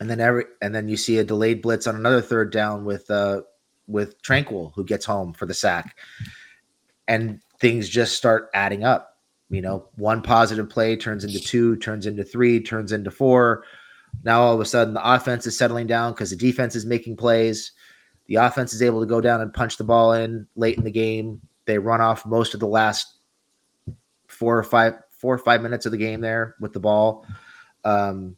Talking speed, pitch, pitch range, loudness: 205 wpm, 115 Hz, 110-115 Hz, -21 LUFS